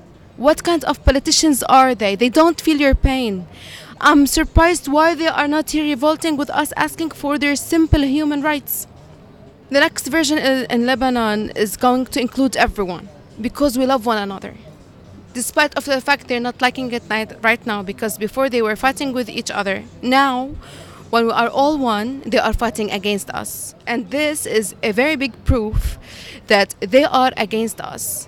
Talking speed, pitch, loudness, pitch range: 175 wpm, 260 Hz, -17 LUFS, 225-290 Hz